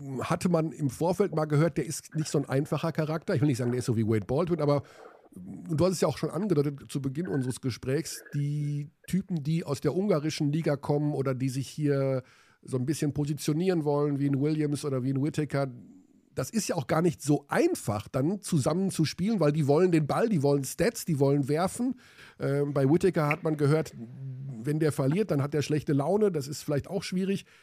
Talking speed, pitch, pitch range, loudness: 220 wpm, 150 Hz, 140-165 Hz, -28 LUFS